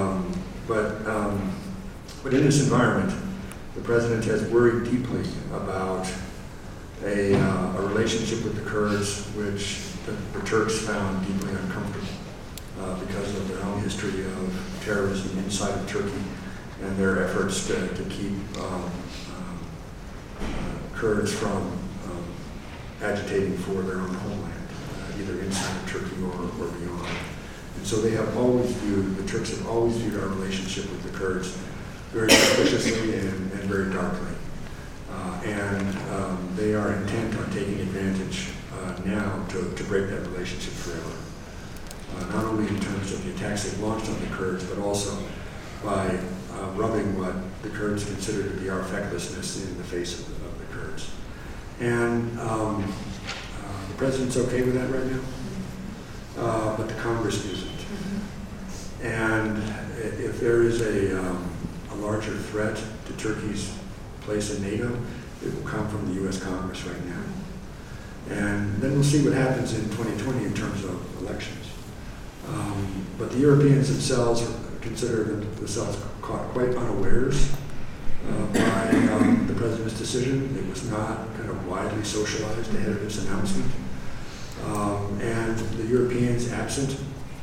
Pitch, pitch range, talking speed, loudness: 100 Hz, 95-110 Hz, 150 wpm, -27 LUFS